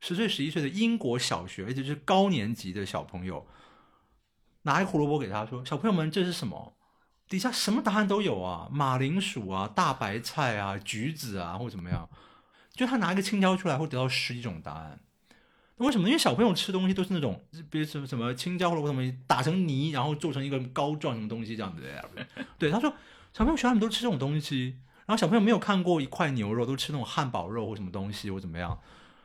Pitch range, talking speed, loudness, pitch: 115-185 Hz, 350 characters per minute, -29 LUFS, 145 Hz